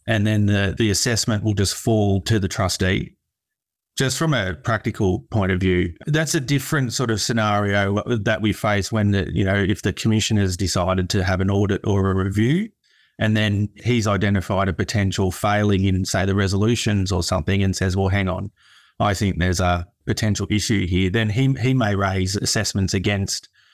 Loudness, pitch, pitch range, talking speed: -21 LUFS, 100 Hz, 95-110 Hz, 190 wpm